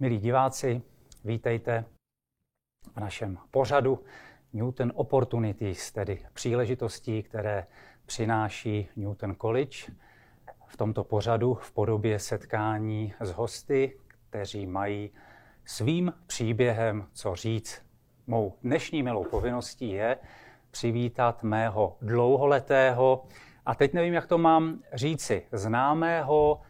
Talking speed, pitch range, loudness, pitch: 100 wpm, 110-130 Hz, -28 LUFS, 115 Hz